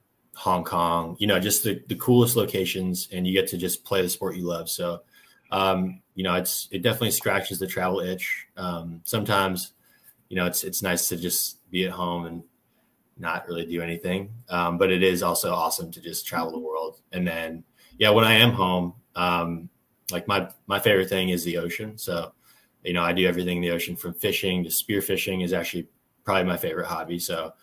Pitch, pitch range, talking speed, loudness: 90 Hz, 85-95 Hz, 205 wpm, -25 LUFS